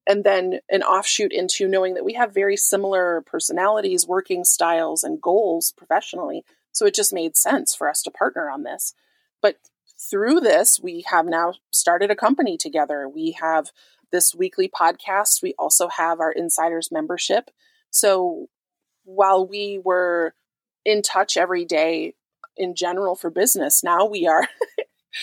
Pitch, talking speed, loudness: 190 Hz, 150 wpm, -20 LUFS